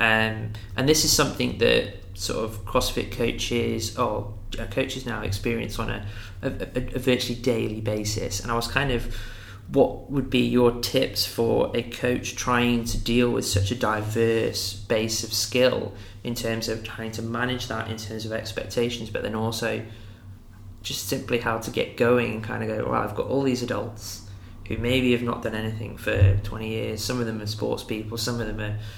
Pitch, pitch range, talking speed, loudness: 110 Hz, 105-120 Hz, 195 wpm, -25 LUFS